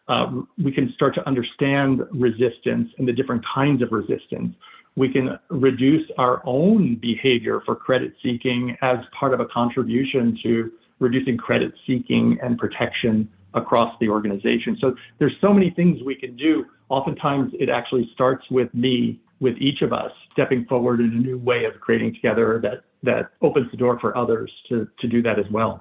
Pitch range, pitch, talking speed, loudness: 120-135 Hz, 125 Hz, 175 wpm, -21 LUFS